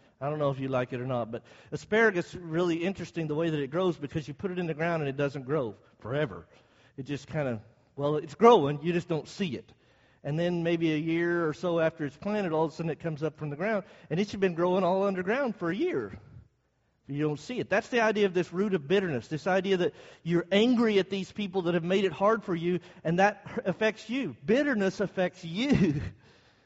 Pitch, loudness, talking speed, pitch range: 170 Hz, -29 LUFS, 240 wpm, 145-195 Hz